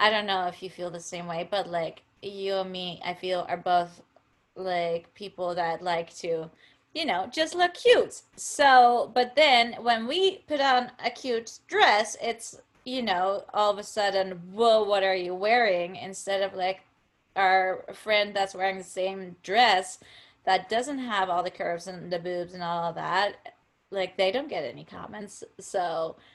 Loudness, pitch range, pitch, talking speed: -26 LUFS, 180-230 Hz, 190 Hz, 180 wpm